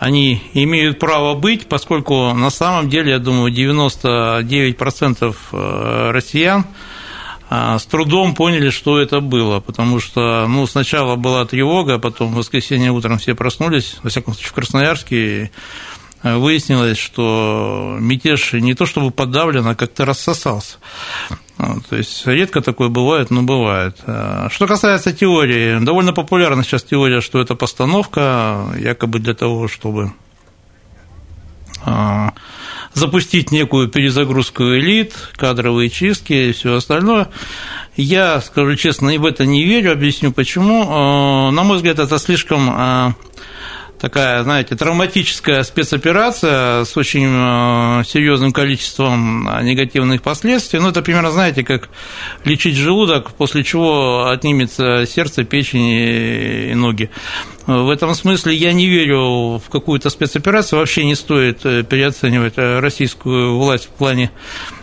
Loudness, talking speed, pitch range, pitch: -14 LUFS, 120 wpm, 120-155 Hz, 135 Hz